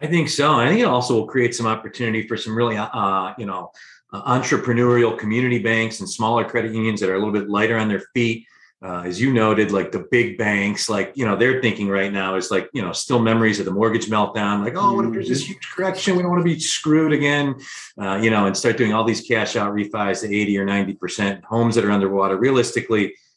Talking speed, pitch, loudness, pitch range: 240 wpm, 115 Hz, -20 LUFS, 100-120 Hz